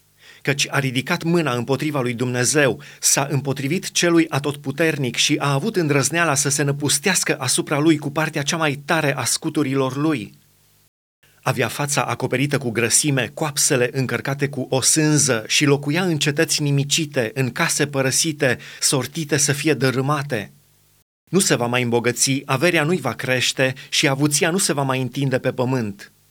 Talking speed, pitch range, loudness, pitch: 155 wpm, 130-155 Hz, -19 LUFS, 140 Hz